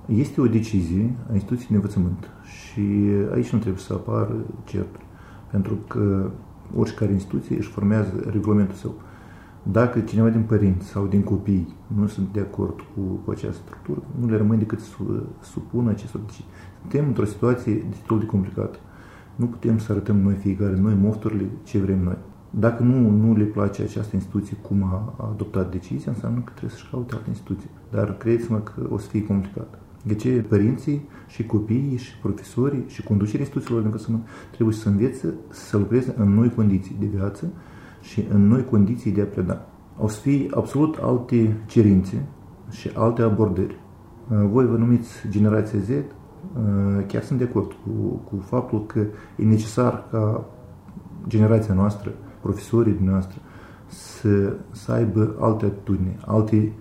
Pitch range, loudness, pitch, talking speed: 100-115 Hz, -23 LUFS, 105 Hz, 160 wpm